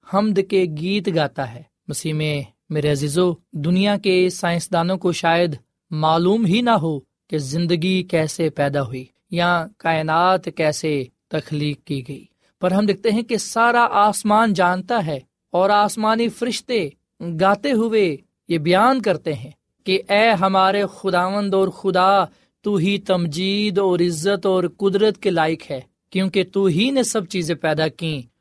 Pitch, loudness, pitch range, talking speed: 180 Hz, -19 LUFS, 155-200 Hz, 150 wpm